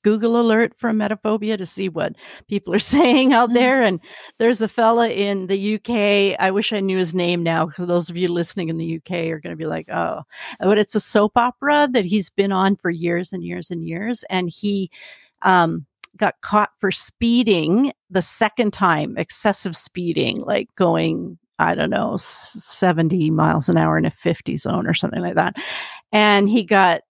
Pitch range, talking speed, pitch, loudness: 175-220 Hz, 195 wpm, 200 Hz, -19 LUFS